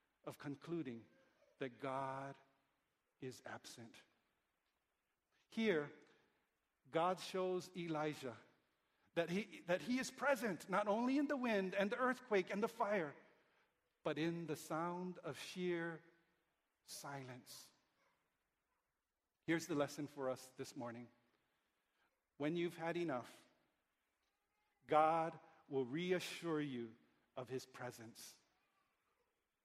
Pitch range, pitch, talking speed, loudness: 135-185 Hz, 165 Hz, 105 wpm, -43 LUFS